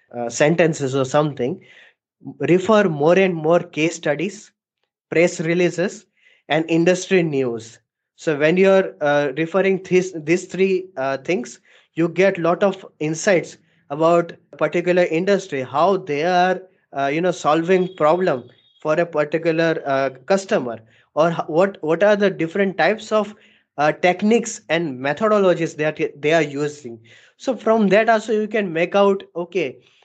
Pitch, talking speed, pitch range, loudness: 170 Hz, 145 wpm, 150-190 Hz, -19 LUFS